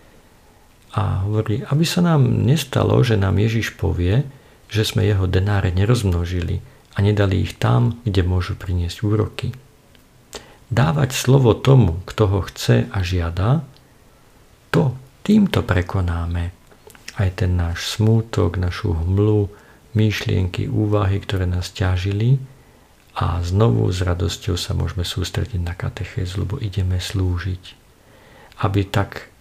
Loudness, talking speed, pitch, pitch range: -20 LUFS, 120 wpm, 105 Hz, 90-115 Hz